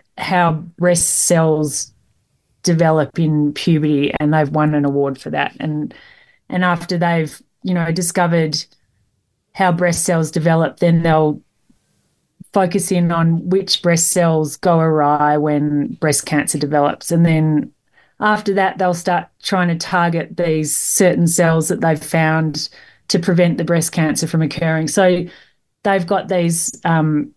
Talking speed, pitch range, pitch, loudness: 145 wpm, 150-180 Hz, 165 Hz, -16 LUFS